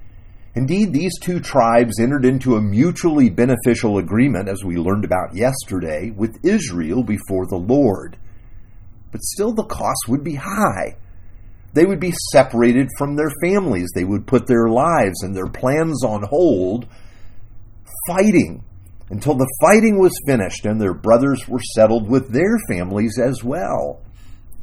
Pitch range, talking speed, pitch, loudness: 95-135 Hz, 145 wpm, 115 Hz, -18 LUFS